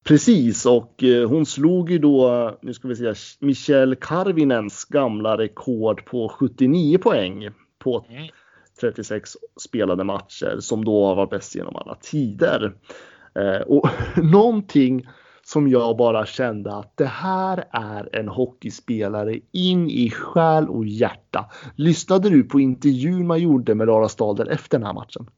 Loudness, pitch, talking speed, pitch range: -20 LUFS, 130 Hz, 140 wpm, 110-155 Hz